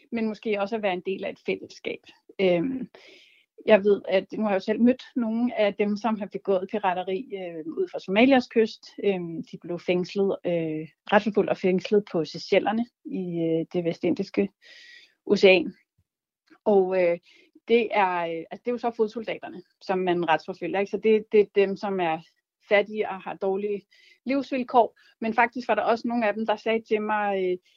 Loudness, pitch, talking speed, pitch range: -25 LUFS, 205 Hz, 180 wpm, 185-225 Hz